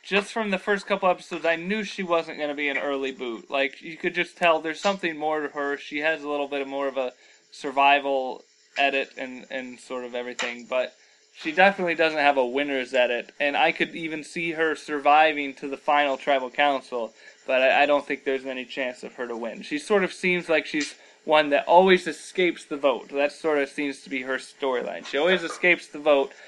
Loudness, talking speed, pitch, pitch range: -24 LUFS, 220 wpm, 145 Hz, 135-170 Hz